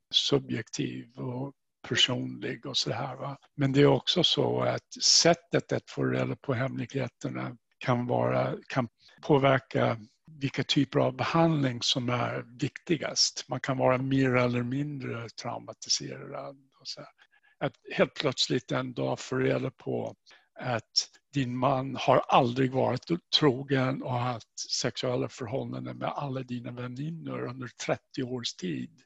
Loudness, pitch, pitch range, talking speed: -29 LUFS, 130 Hz, 120-140 Hz, 140 wpm